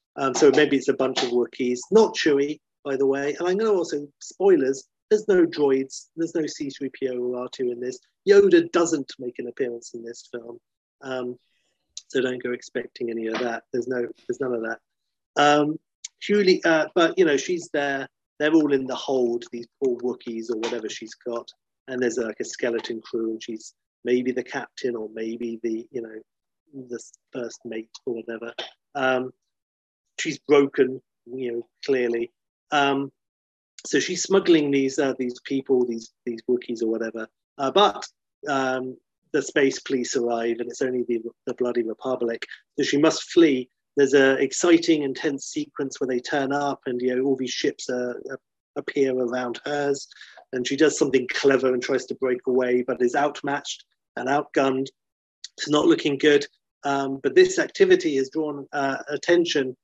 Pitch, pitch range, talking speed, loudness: 130 Hz, 120-145 Hz, 175 wpm, -24 LUFS